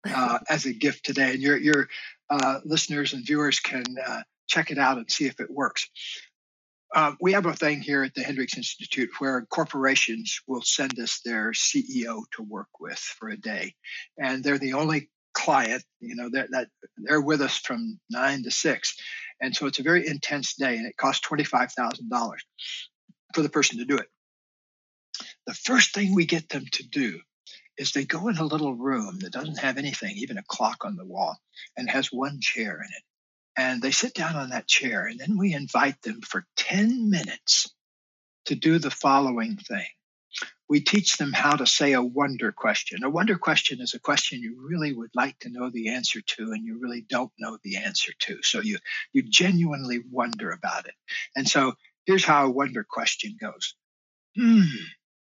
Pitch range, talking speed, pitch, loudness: 130-185 Hz, 195 wpm, 145 Hz, -25 LUFS